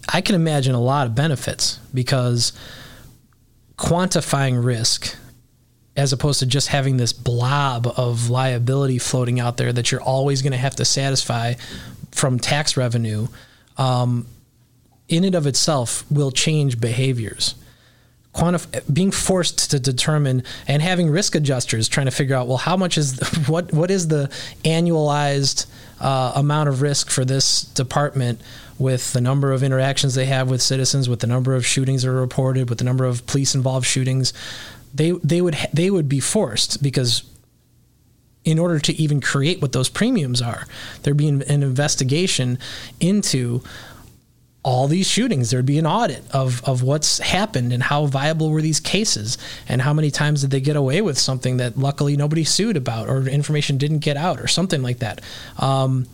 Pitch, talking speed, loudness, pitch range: 135 Hz, 170 wpm, -19 LUFS, 125-150 Hz